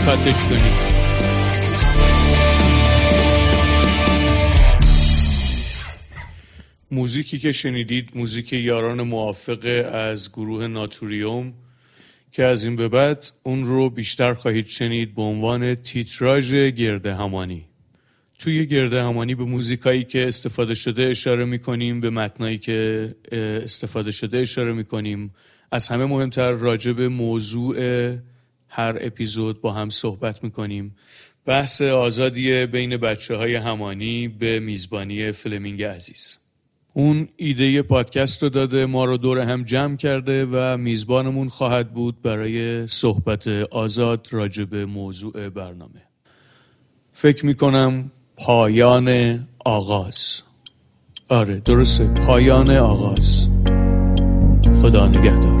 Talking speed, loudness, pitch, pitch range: 105 wpm, -19 LUFS, 115 Hz, 105-125 Hz